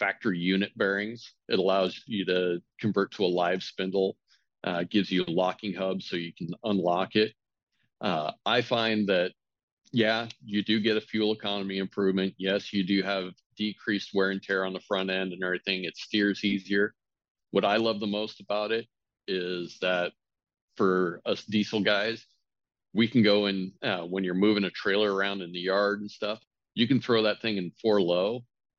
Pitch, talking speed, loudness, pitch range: 100 Hz, 185 wpm, -28 LUFS, 95-105 Hz